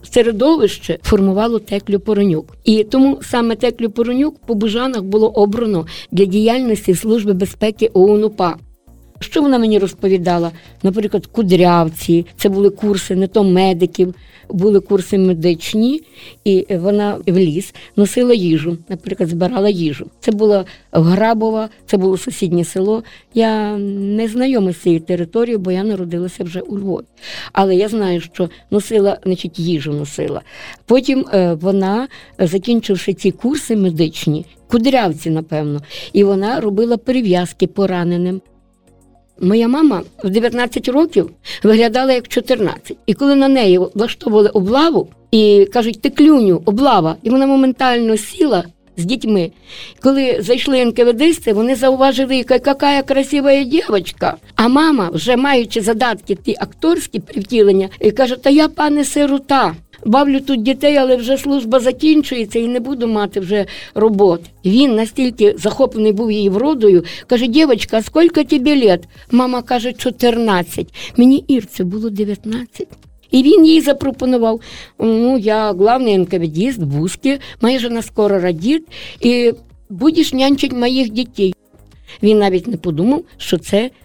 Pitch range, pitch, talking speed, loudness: 190-255 Hz, 220 Hz, 130 wpm, -15 LUFS